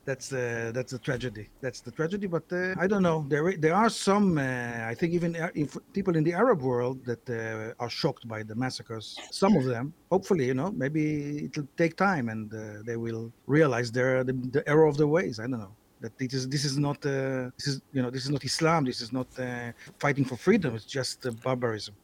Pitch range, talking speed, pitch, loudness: 120-160 Hz, 225 wpm, 130 Hz, -28 LUFS